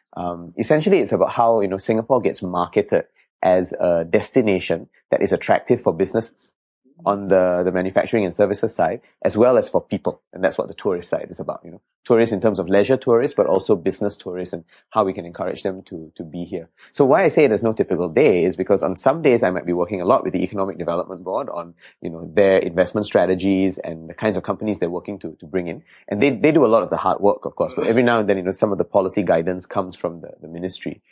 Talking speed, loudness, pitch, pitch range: 250 wpm, -20 LUFS, 95 Hz, 90-105 Hz